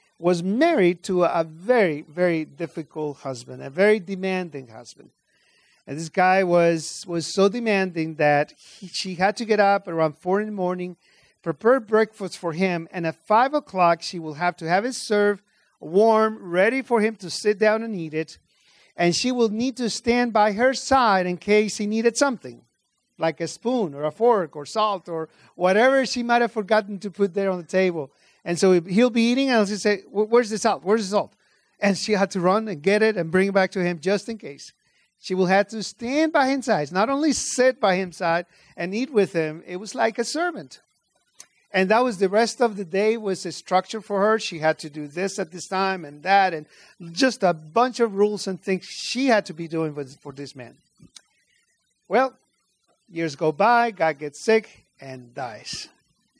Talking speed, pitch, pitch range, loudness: 205 wpm, 195 Hz, 170-220 Hz, -22 LUFS